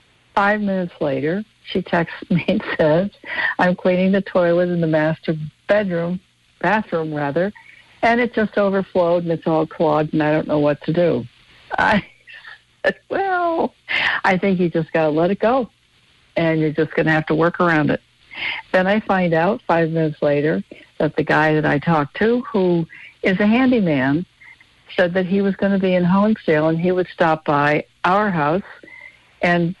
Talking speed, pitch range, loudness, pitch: 180 wpm, 160-200 Hz, -19 LUFS, 180 Hz